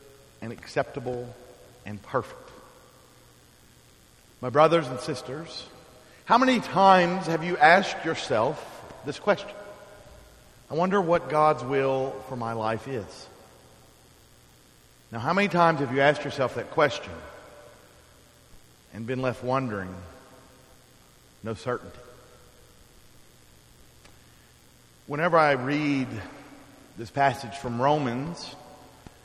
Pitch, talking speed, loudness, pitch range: 130 Hz, 100 wpm, -25 LUFS, 115-155 Hz